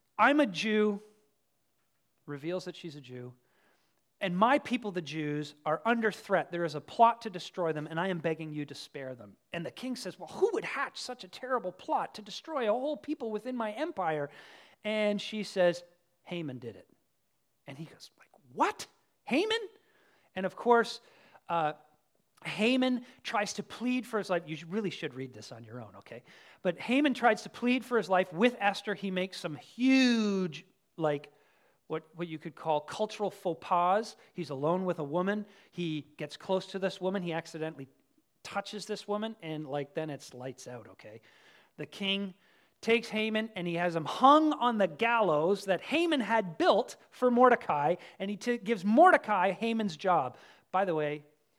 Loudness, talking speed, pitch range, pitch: -31 LUFS, 185 wpm, 160-225 Hz, 190 Hz